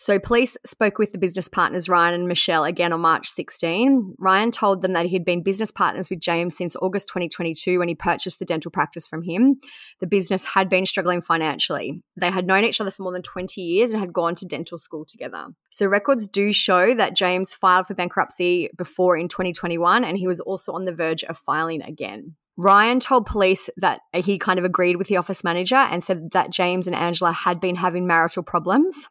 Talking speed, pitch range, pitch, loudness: 215 wpm, 175-195 Hz, 185 Hz, -20 LUFS